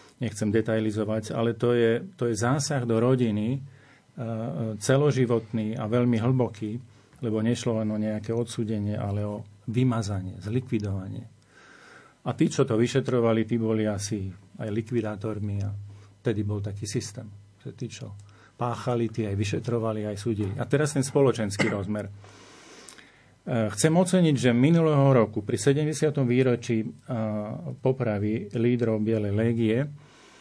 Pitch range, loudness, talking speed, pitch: 105-125 Hz, -26 LUFS, 135 wpm, 115 Hz